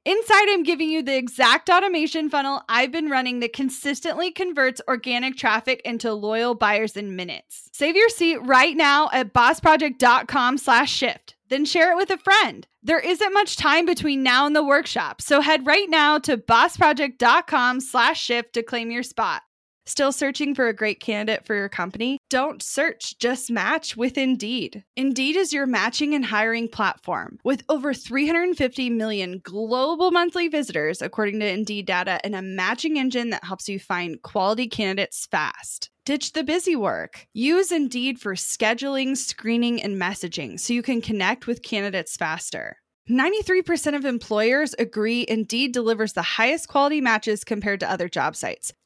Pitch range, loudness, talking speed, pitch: 220-300 Hz, -21 LUFS, 160 wpm, 255 Hz